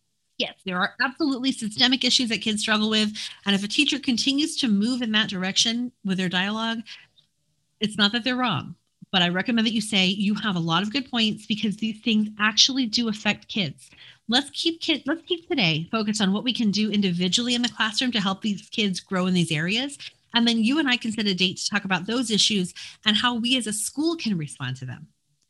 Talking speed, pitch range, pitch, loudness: 225 wpm, 190-245 Hz, 215 Hz, -23 LUFS